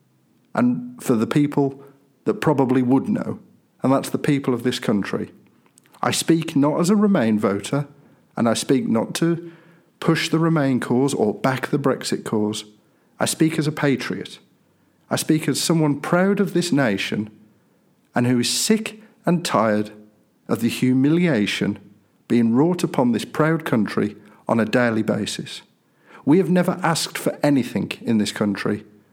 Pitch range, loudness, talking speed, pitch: 110-165 Hz, -21 LUFS, 160 wpm, 140 Hz